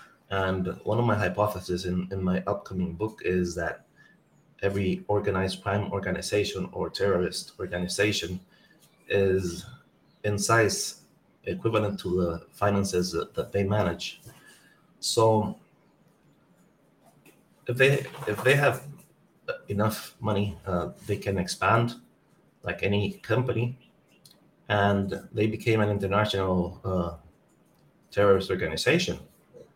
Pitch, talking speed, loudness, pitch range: 100 Hz, 105 wpm, -27 LUFS, 95-110 Hz